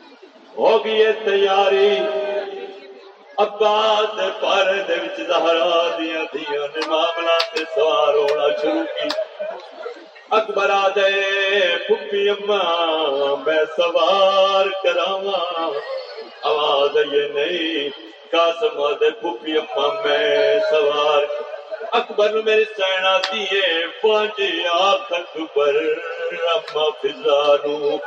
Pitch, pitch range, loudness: 195 Hz, 155-215 Hz, -19 LUFS